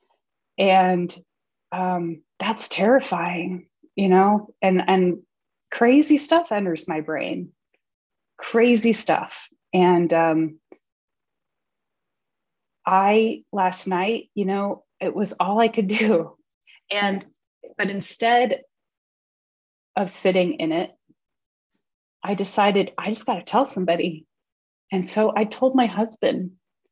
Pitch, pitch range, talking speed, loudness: 200 Hz, 180-230 Hz, 110 wpm, -21 LUFS